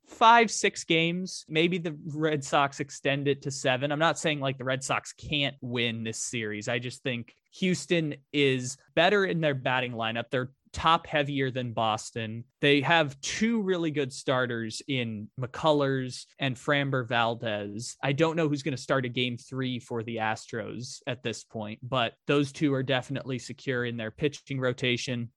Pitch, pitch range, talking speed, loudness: 135 Hz, 120-150 Hz, 175 wpm, -28 LUFS